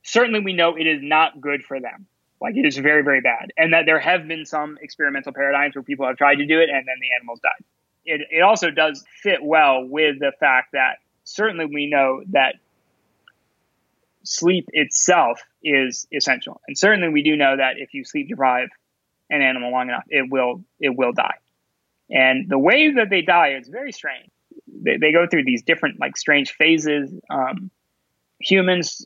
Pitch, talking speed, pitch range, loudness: 150 Hz, 190 wpm, 135-175 Hz, -18 LUFS